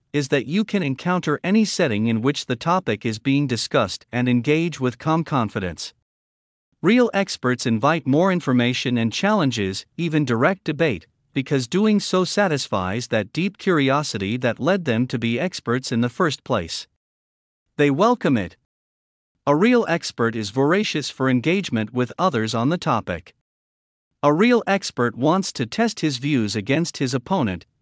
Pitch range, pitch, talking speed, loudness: 115-170 Hz, 135 Hz, 155 wpm, -21 LUFS